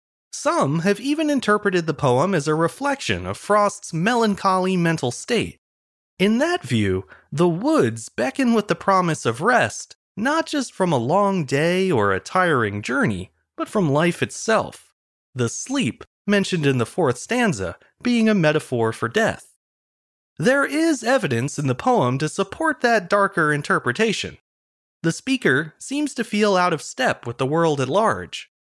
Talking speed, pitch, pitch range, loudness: 155 wpm, 180 Hz, 135-220 Hz, -21 LUFS